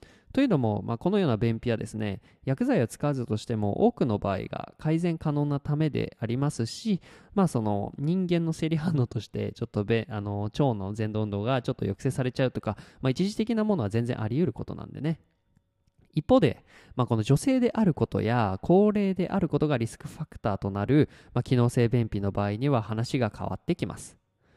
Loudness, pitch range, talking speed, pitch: -28 LUFS, 110-155 Hz, 400 characters per minute, 125 Hz